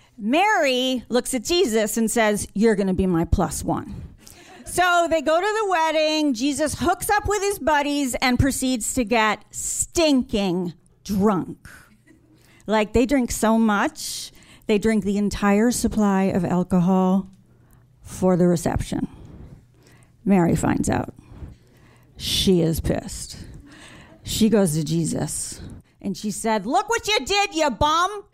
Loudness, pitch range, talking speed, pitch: -21 LUFS, 190-305 Hz, 140 wpm, 225 Hz